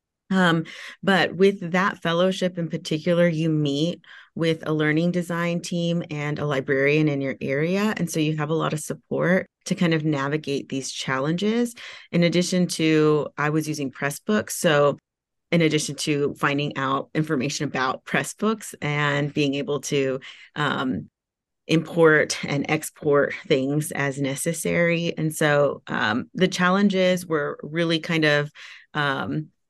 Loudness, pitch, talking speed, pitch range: -23 LUFS, 155 Hz, 145 wpm, 145-175 Hz